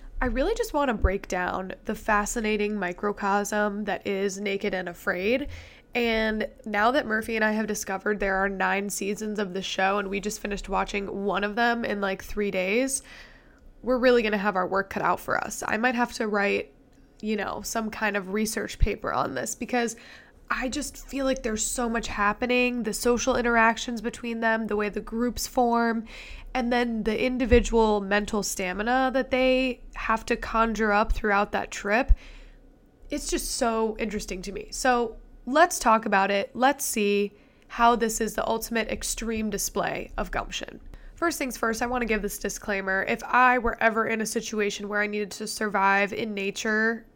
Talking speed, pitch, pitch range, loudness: 185 wpm, 220 Hz, 205-240 Hz, -26 LUFS